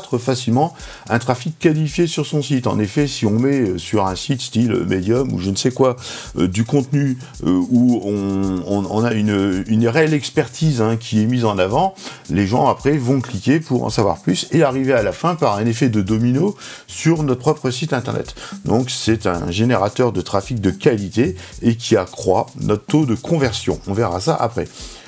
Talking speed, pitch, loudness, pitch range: 200 wpm, 120 Hz, -18 LUFS, 105-140 Hz